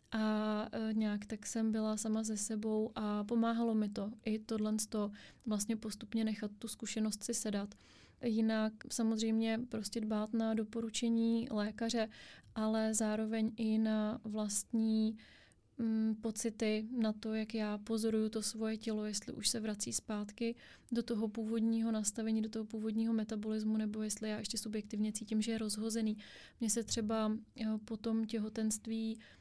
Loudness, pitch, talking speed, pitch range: -37 LUFS, 220 Hz, 145 wpm, 215-225 Hz